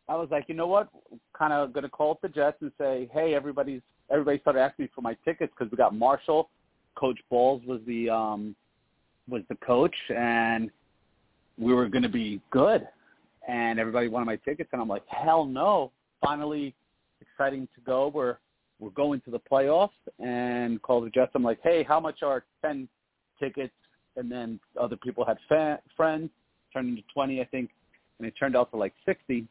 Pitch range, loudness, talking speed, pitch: 120-150 Hz, -28 LUFS, 195 wpm, 130 Hz